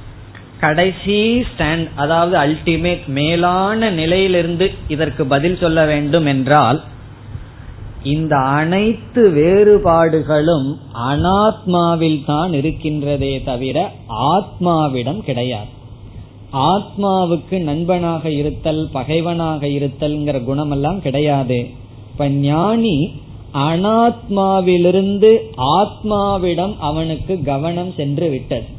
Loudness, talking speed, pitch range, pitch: -16 LUFS, 75 wpm, 140-180 Hz, 155 Hz